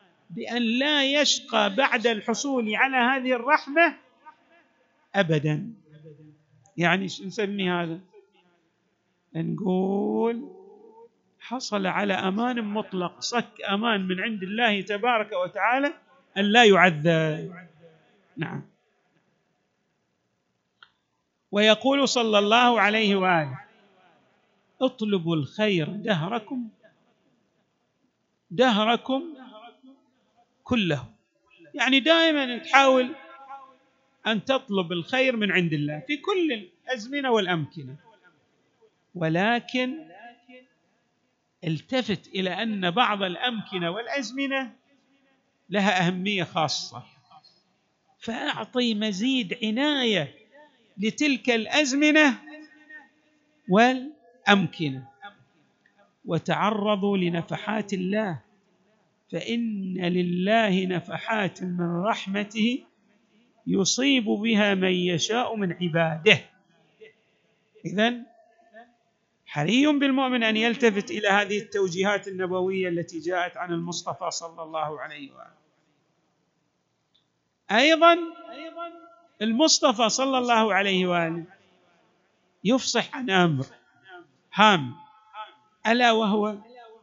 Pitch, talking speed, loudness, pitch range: 215 Hz, 75 wpm, -24 LUFS, 180-255 Hz